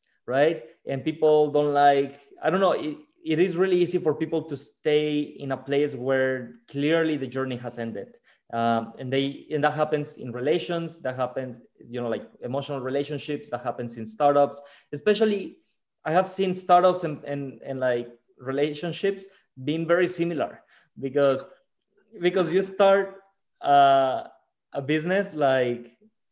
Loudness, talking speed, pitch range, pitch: -25 LUFS, 150 wpm, 130-170 Hz, 145 Hz